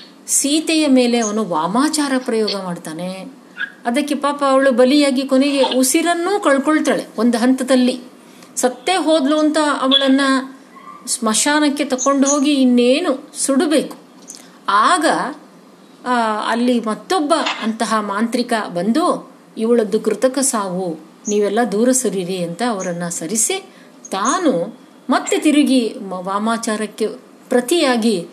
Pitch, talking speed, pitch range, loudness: 255 Hz, 95 wpm, 220-285 Hz, -17 LUFS